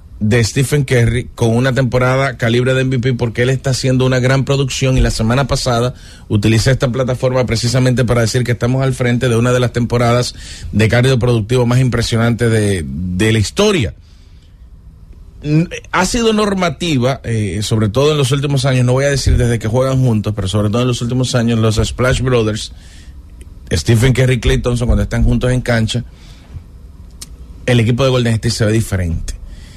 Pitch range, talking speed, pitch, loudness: 105-130 Hz, 180 wpm, 120 Hz, -14 LUFS